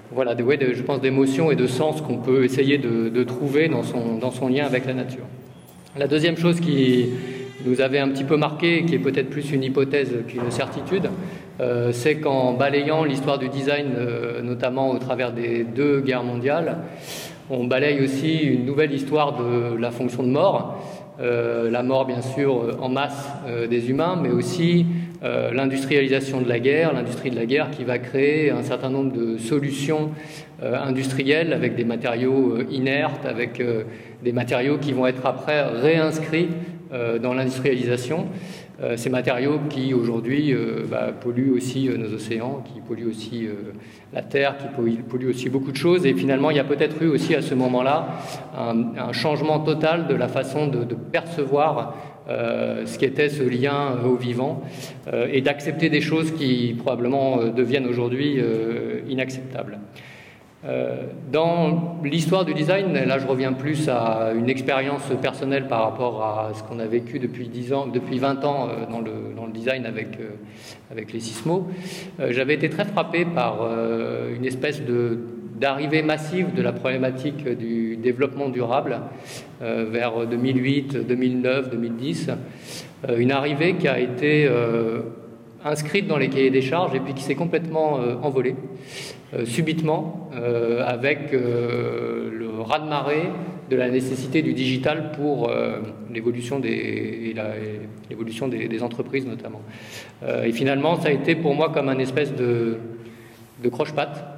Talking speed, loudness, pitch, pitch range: 170 wpm, -23 LUFS, 130 Hz, 120-145 Hz